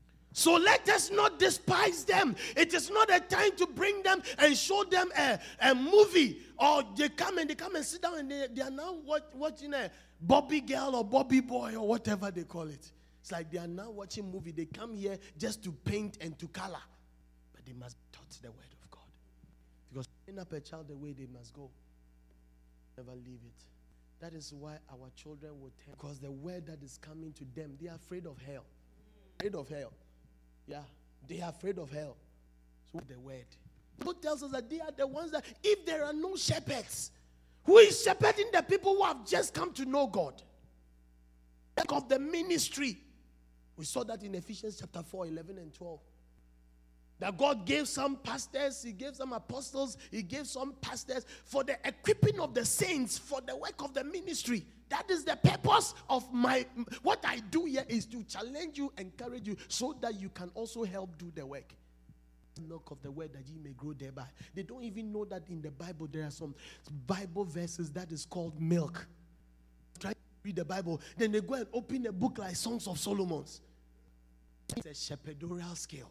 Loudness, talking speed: -32 LUFS, 200 wpm